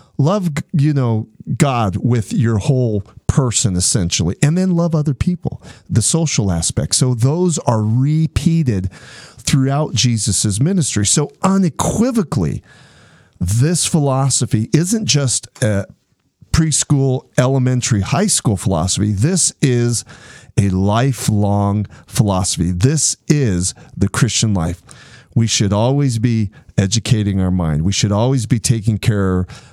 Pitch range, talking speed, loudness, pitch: 105-145 Hz, 120 wpm, -16 LUFS, 125 Hz